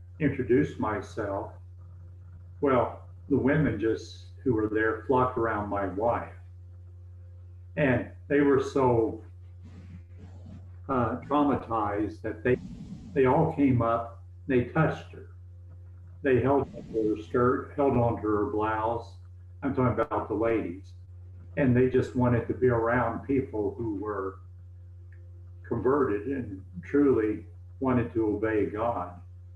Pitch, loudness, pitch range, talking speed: 105 Hz, -28 LUFS, 90-120 Hz, 120 wpm